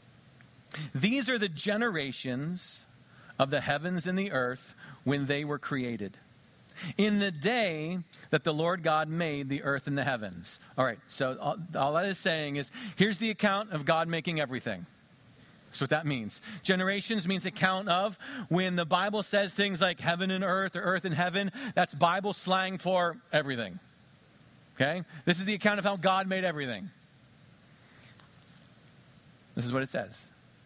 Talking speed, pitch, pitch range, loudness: 160 wpm, 165 Hz, 140-190 Hz, -30 LUFS